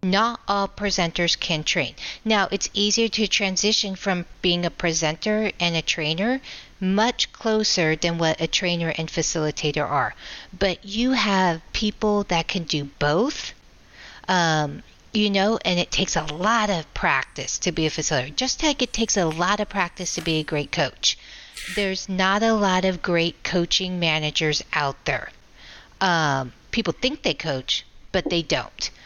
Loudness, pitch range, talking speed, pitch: -22 LUFS, 160-205 Hz, 165 wpm, 180 Hz